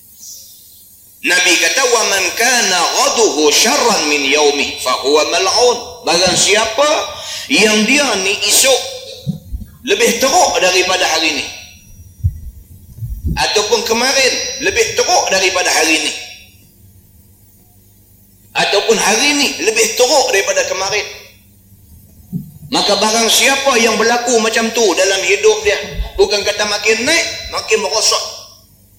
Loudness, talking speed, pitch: -12 LUFS, 110 wpm, 195 Hz